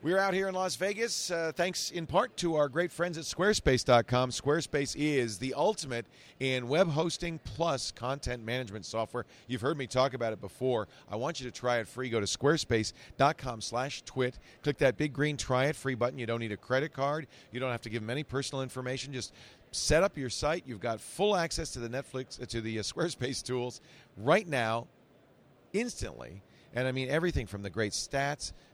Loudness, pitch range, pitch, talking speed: -32 LUFS, 120-155 Hz, 130 Hz, 205 wpm